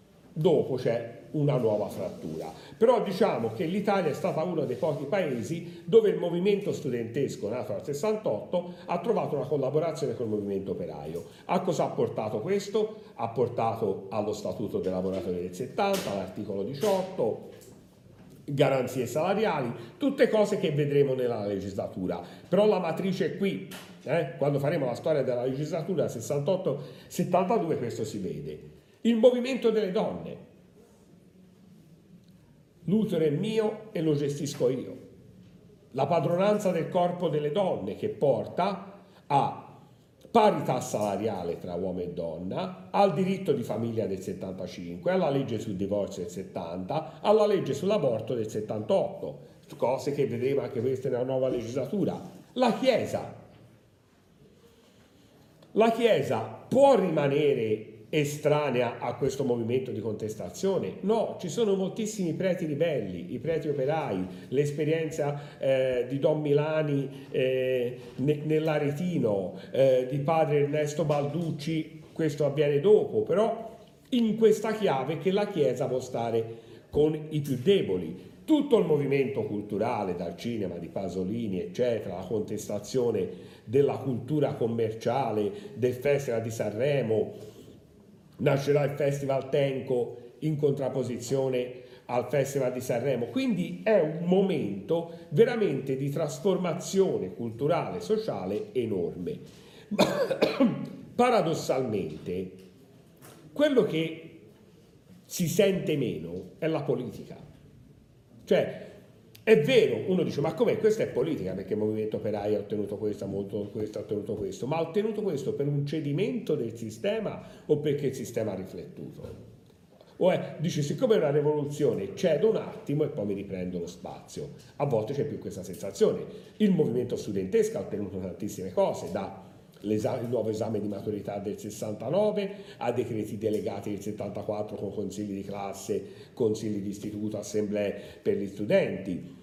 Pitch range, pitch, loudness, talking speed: 115-190 Hz, 145 Hz, -29 LUFS, 135 wpm